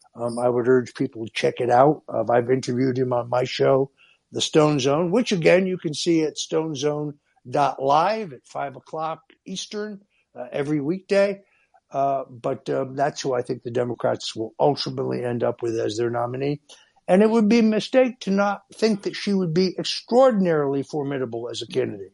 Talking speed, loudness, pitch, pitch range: 185 wpm, -23 LUFS, 145 Hz, 125-190 Hz